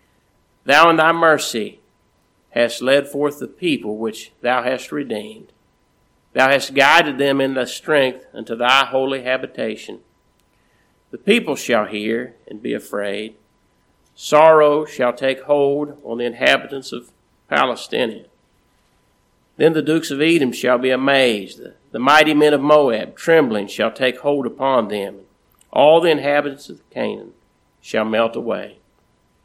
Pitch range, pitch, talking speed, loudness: 120-145 Hz, 135 Hz, 140 wpm, -17 LUFS